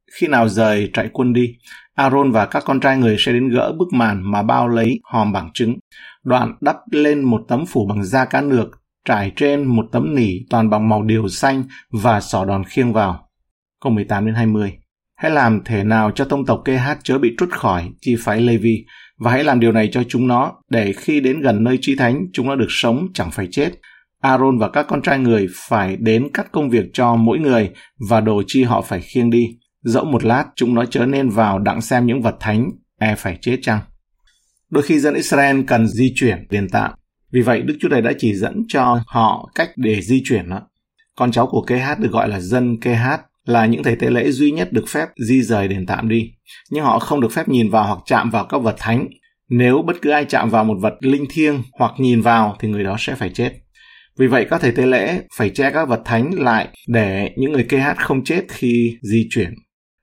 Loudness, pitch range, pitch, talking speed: -17 LUFS, 110-130 Hz, 120 Hz, 230 wpm